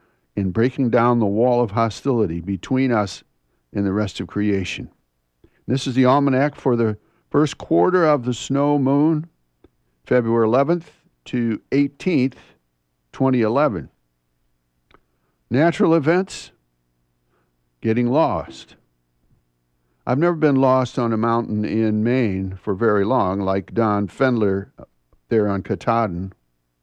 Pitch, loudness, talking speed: 110 Hz, -20 LUFS, 120 wpm